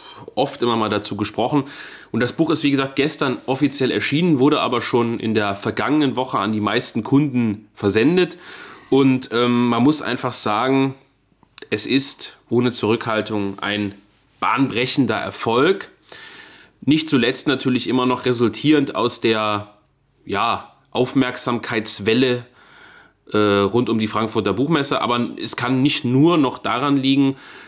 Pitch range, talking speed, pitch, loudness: 110-135 Hz, 135 wpm, 125 Hz, -19 LUFS